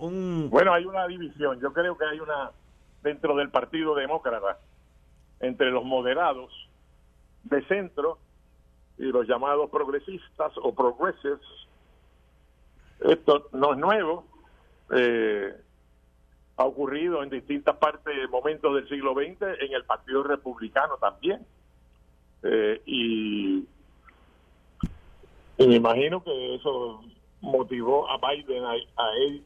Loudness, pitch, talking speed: -26 LUFS, 125 Hz, 115 wpm